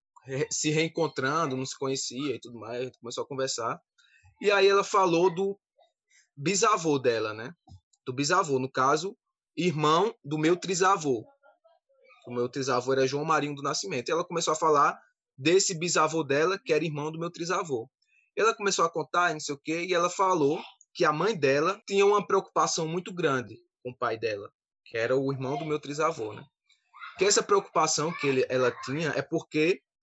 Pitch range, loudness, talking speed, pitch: 140-195 Hz, -27 LUFS, 180 wpm, 160 Hz